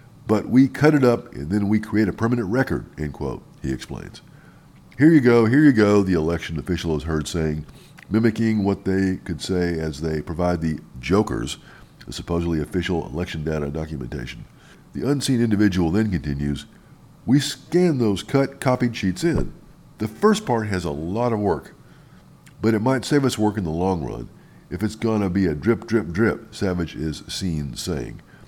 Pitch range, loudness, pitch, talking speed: 80-115 Hz, -22 LUFS, 100 Hz, 180 wpm